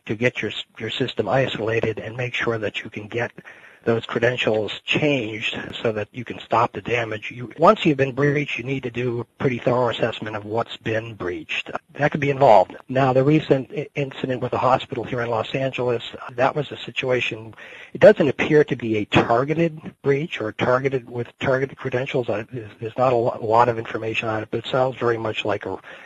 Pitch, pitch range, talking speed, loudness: 120 Hz, 115-135 Hz, 205 wpm, -22 LUFS